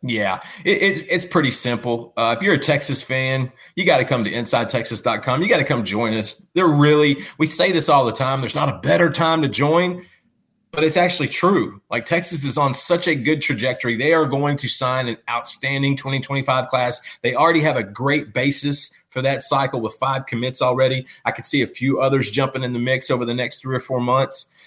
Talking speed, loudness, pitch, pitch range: 215 wpm, -19 LUFS, 135 Hz, 125-150 Hz